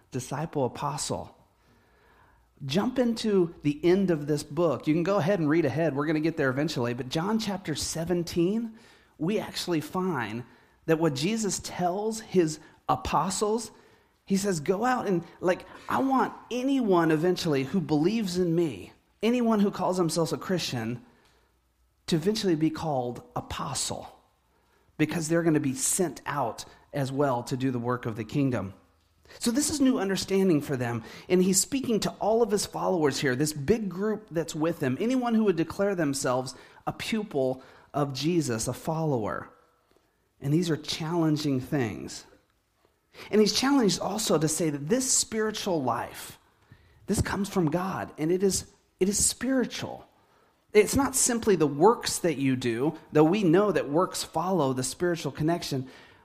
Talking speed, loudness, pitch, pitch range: 160 wpm, -27 LUFS, 170 Hz, 145-200 Hz